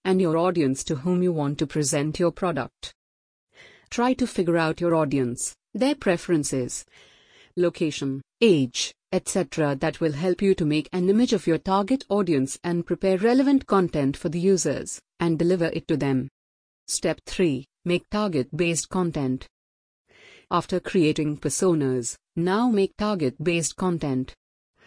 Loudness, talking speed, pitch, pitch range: -24 LUFS, 145 wpm, 165 Hz, 140-185 Hz